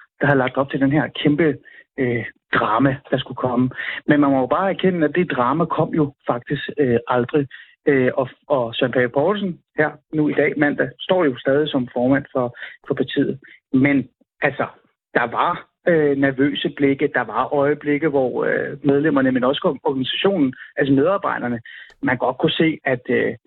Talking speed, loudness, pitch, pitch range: 175 wpm, -20 LUFS, 140 Hz, 130-150 Hz